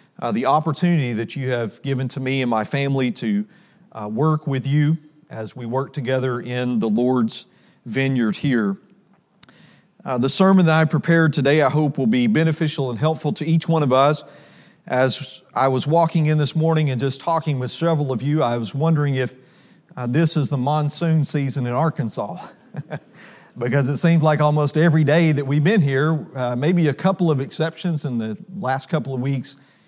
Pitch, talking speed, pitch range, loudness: 145 Hz, 190 wpm, 130-160 Hz, -20 LUFS